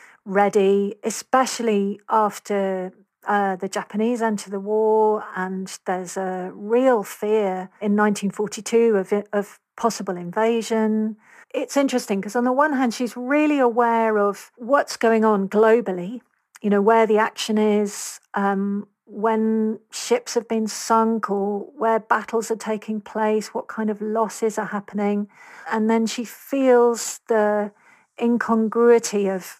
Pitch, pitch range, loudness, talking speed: 215 Hz, 205-230 Hz, -21 LUFS, 135 wpm